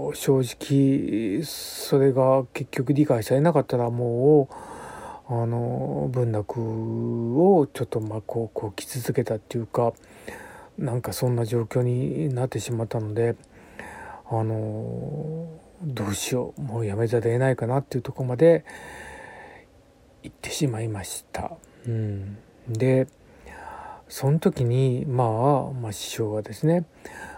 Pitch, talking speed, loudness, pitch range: 125 Hz, 250 characters per minute, -25 LUFS, 115-145 Hz